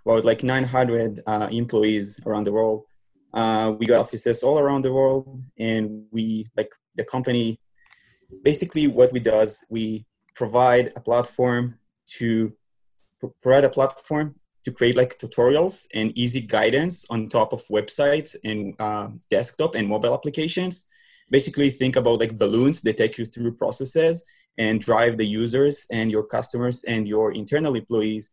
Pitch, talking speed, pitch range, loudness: 120 Hz, 155 wpm, 110-135 Hz, -22 LUFS